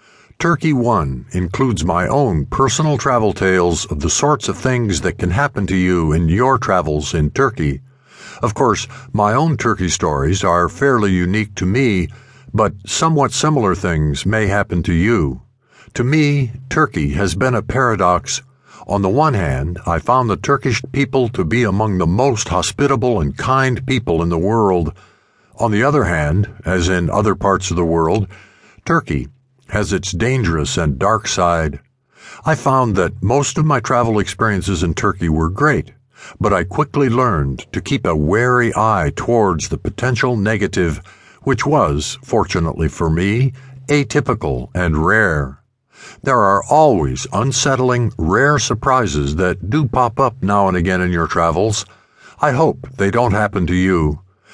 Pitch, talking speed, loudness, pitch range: 100 Hz, 160 wpm, -16 LUFS, 85-125 Hz